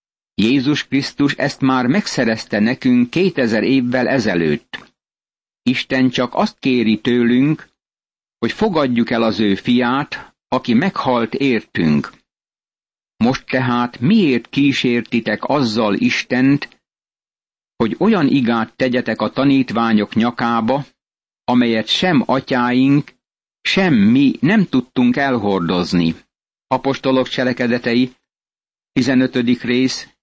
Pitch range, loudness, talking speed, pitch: 115-135 Hz, -16 LUFS, 95 wpm, 125 Hz